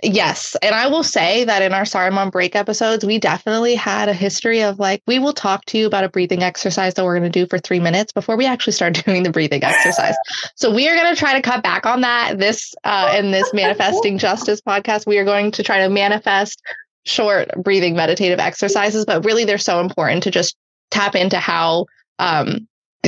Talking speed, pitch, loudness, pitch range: 215 wpm, 200 Hz, -16 LUFS, 185-220 Hz